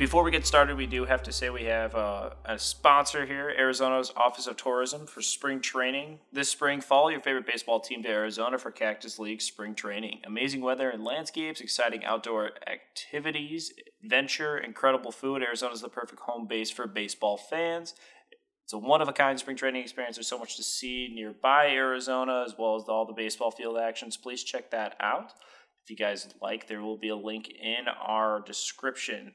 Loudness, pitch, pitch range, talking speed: -29 LUFS, 125 Hz, 110-140 Hz, 190 wpm